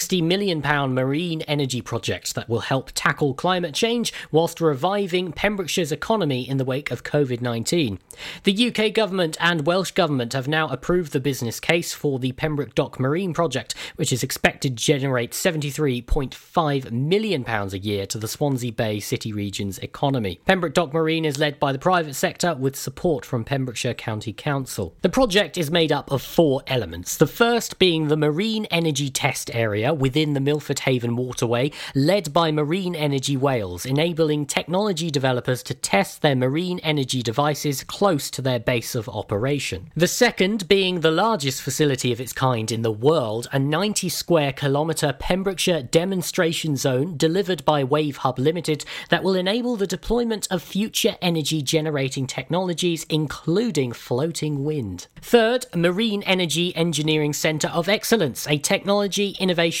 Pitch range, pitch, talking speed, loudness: 130-175 Hz, 150 Hz, 160 wpm, -22 LUFS